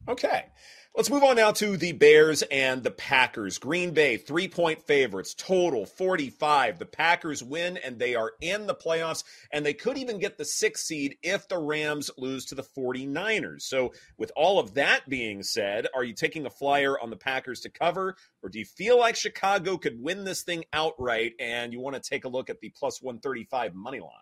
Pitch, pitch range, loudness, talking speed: 155 Hz, 130-190 Hz, -26 LUFS, 205 wpm